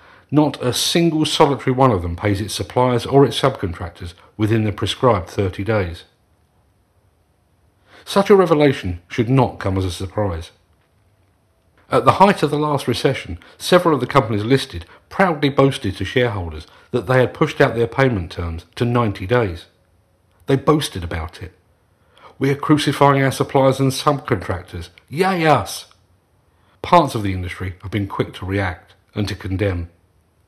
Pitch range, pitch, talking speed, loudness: 90-135 Hz, 105 Hz, 155 wpm, -18 LUFS